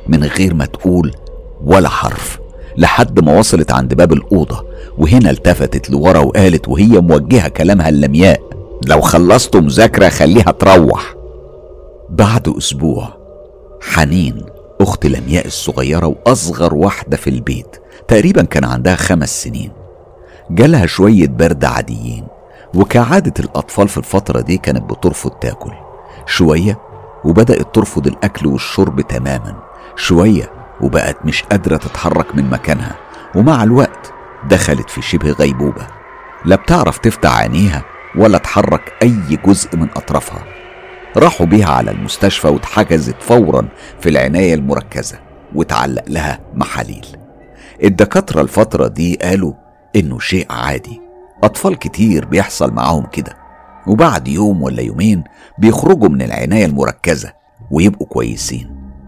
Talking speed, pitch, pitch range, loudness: 115 wpm, 80 Hz, 70-95 Hz, -12 LUFS